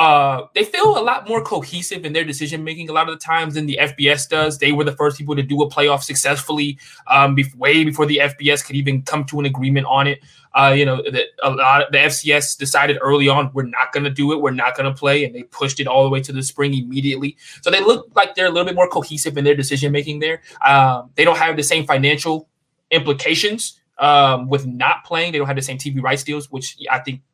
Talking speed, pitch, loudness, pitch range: 255 wpm, 145 Hz, -17 LUFS, 140-155 Hz